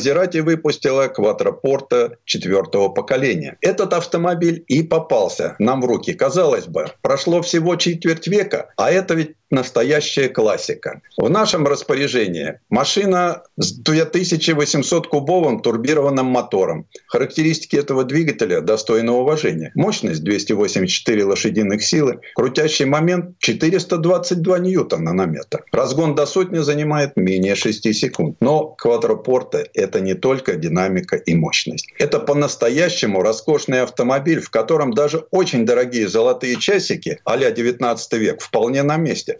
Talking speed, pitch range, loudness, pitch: 120 wpm, 130-180 Hz, -18 LUFS, 155 Hz